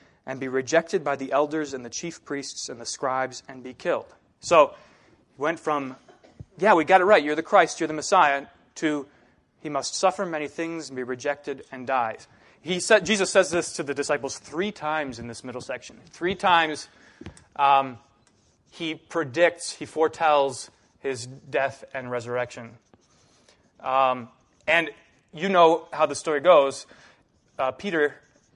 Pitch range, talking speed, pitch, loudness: 130-165 Hz, 160 wpm, 145 Hz, -24 LUFS